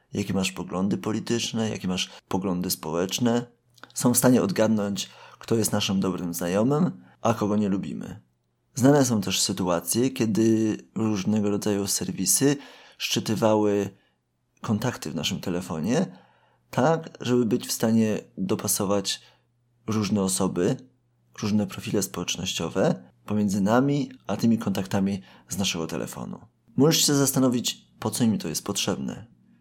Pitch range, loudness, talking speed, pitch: 95-120 Hz, -25 LUFS, 125 wpm, 105 Hz